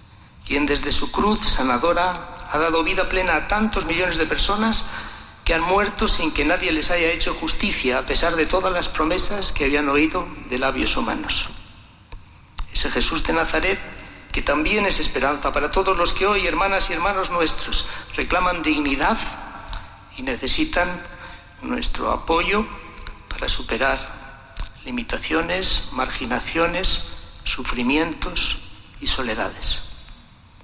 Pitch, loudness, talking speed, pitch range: 170 Hz, -21 LUFS, 130 wpm, 145-185 Hz